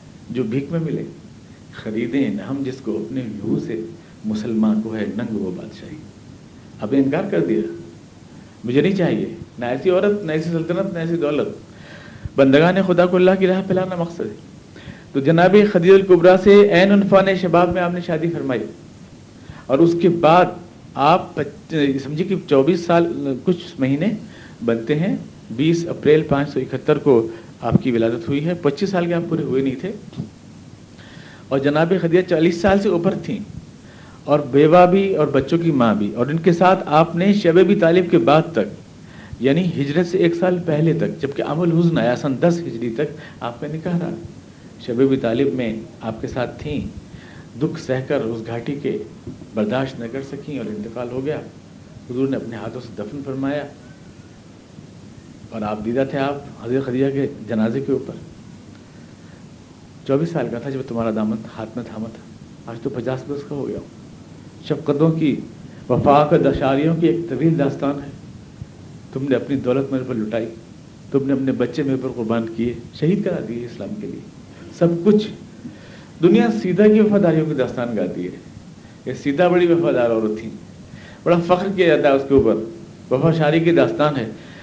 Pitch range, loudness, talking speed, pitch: 125-175 Hz, -18 LUFS, 180 wpm, 145 Hz